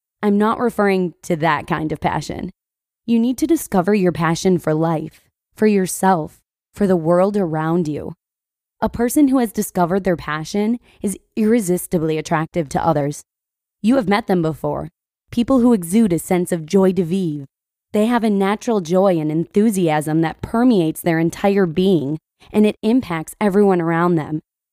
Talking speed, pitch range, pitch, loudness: 165 wpm, 165-210 Hz, 185 Hz, -18 LUFS